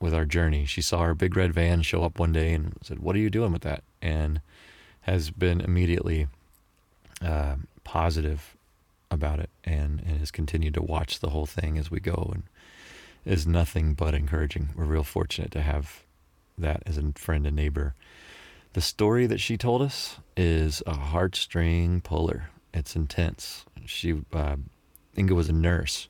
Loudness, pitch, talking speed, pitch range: -28 LUFS, 80 Hz, 170 wpm, 75-90 Hz